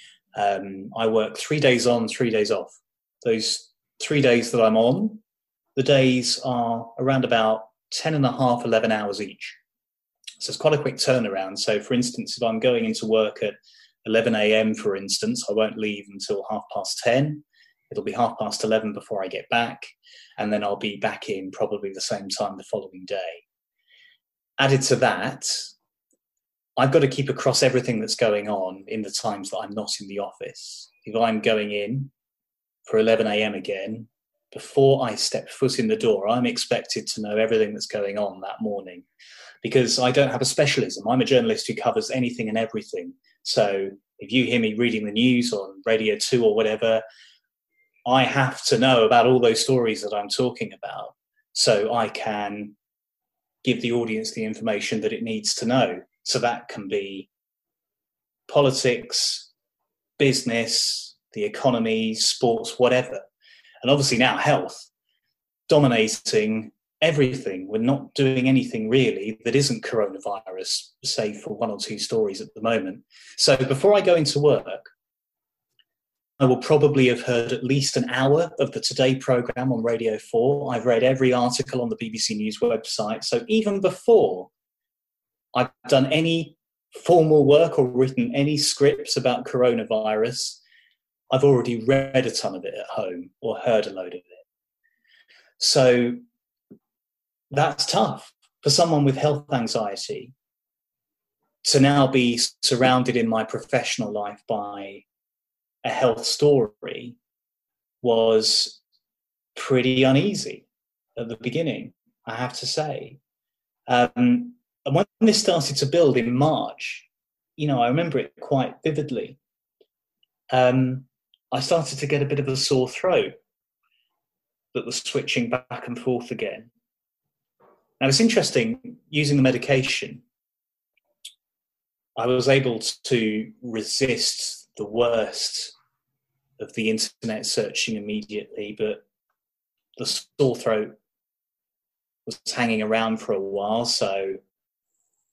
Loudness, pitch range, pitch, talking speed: -22 LUFS, 110-150 Hz, 130 Hz, 150 wpm